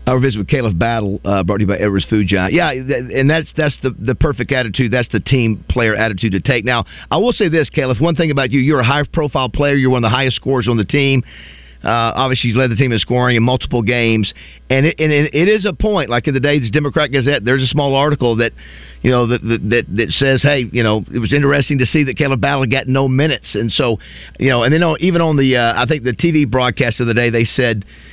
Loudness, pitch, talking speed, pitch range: -15 LUFS, 130 Hz, 270 wpm, 115-145 Hz